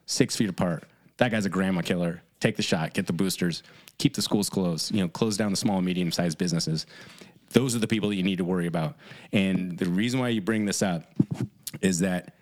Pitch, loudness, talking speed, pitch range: 95 Hz, -27 LUFS, 230 wpm, 90-110 Hz